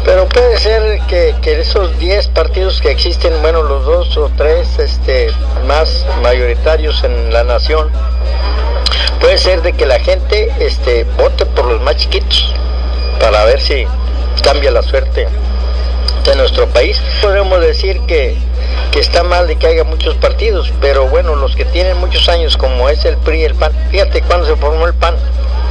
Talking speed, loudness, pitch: 170 wpm, -12 LUFS, 80 Hz